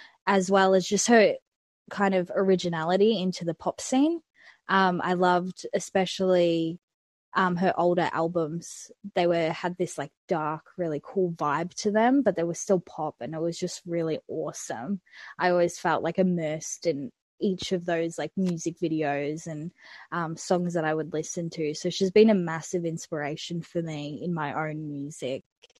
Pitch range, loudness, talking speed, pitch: 160-190 Hz, -27 LUFS, 170 wpm, 175 Hz